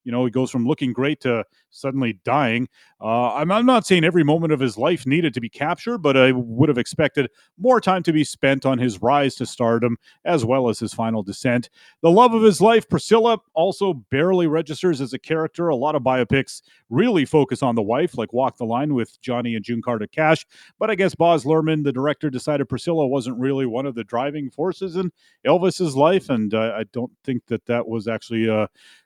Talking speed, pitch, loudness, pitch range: 215 wpm, 135 Hz, -20 LUFS, 120-165 Hz